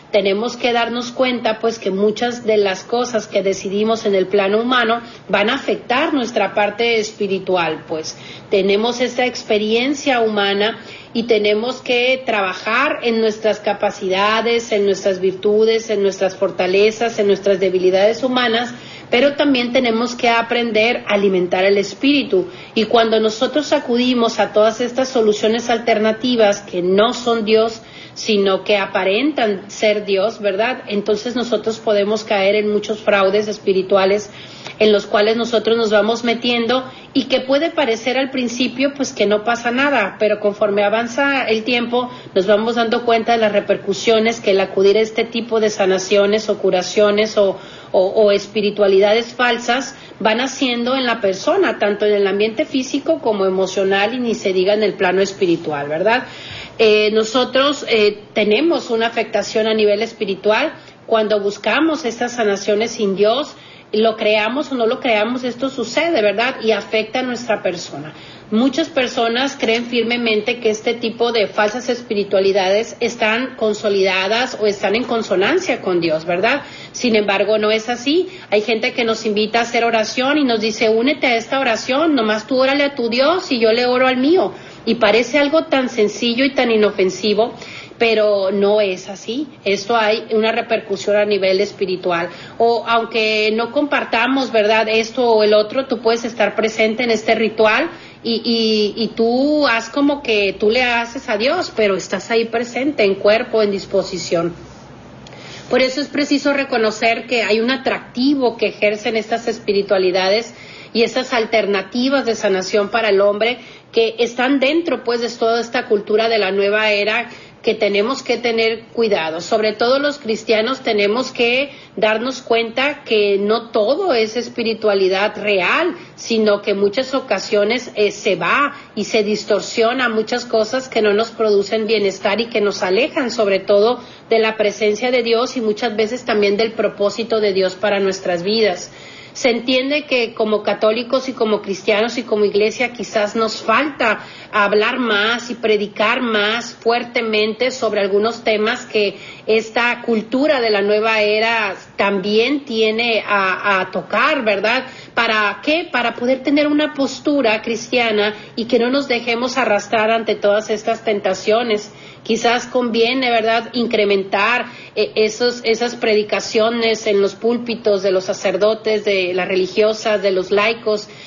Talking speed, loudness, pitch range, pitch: 155 wpm, -17 LUFS, 205-240 Hz, 220 Hz